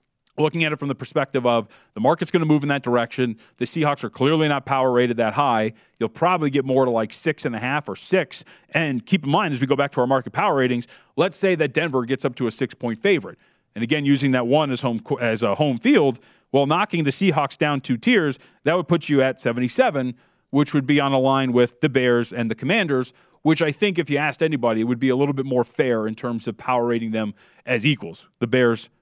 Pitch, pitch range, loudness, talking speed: 135 Hz, 120-150 Hz, -21 LUFS, 250 wpm